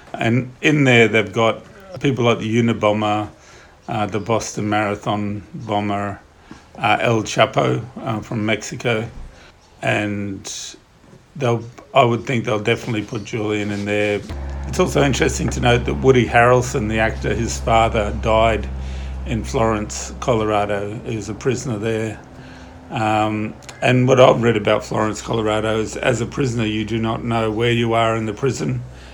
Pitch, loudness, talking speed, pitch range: 110 Hz, -19 LUFS, 150 wpm, 105-120 Hz